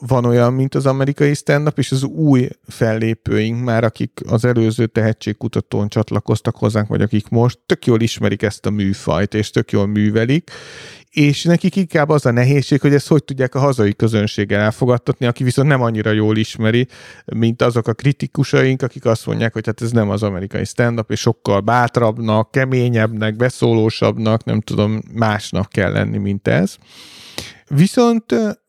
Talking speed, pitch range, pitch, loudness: 160 wpm, 110-135 Hz, 115 Hz, -17 LUFS